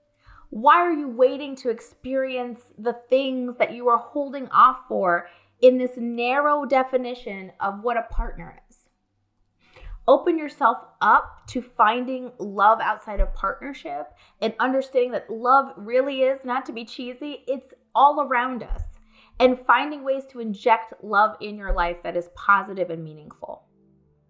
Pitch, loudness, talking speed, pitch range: 245 Hz, -22 LUFS, 150 wpm, 215-265 Hz